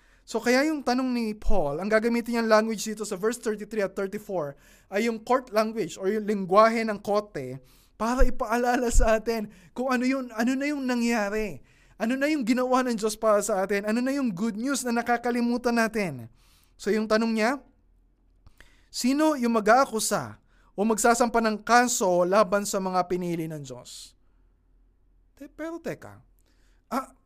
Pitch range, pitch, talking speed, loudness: 195-240 Hz, 220 Hz, 160 wpm, -26 LUFS